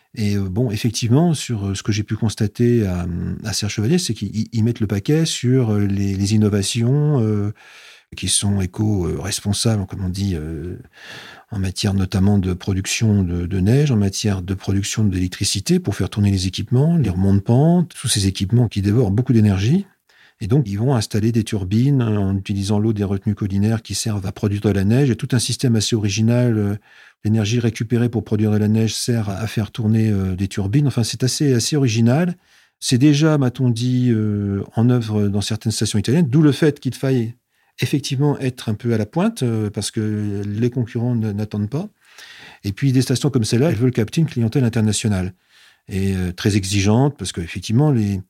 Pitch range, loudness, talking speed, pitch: 100-125 Hz, -19 LUFS, 190 wpm, 110 Hz